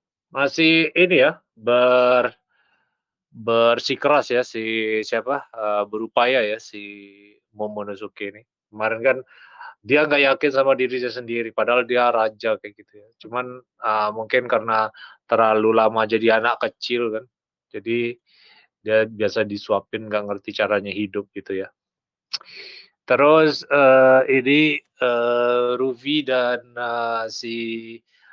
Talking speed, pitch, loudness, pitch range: 115 wpm, 115 Hz, -20 LUFS, 110-130 Hz